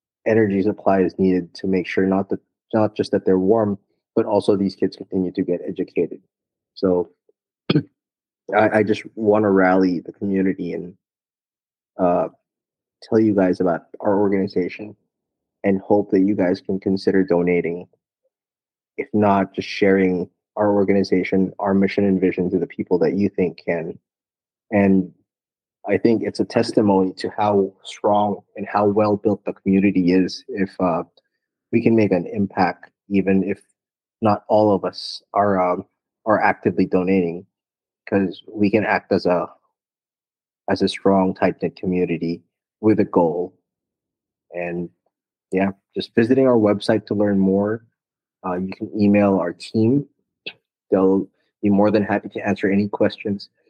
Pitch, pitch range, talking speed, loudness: 100 Hz, 95-105 Hz, 155 wpm, -20 LUFS